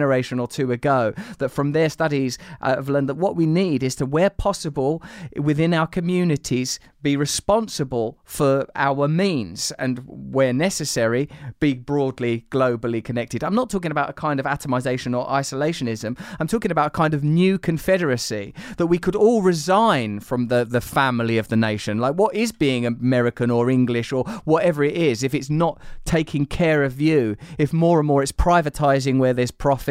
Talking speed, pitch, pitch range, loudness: 185 wpm, 140 Hz, 125-160 Hz, -21 LUFS